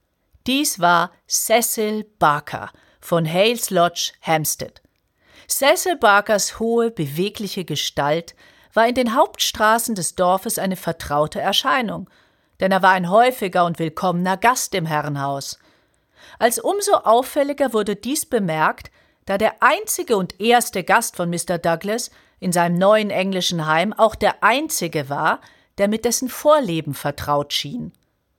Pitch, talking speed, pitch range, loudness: 200 Hz, 130 wpm, 170-235 Hz, -19 LUFS